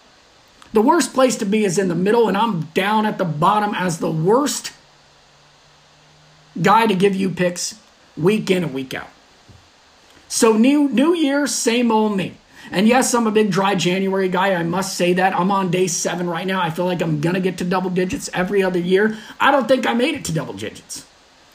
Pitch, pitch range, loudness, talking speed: 195 Hz, 180-225 Hz, -18 LUFS, 210 wpm